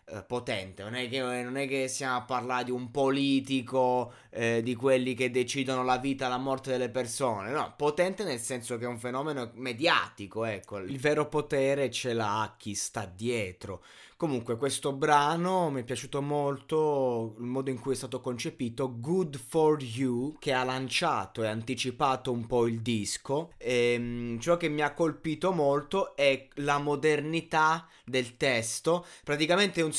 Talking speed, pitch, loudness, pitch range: 170 wpm, 130 Hz, -30 LUFS, 120-145 Hz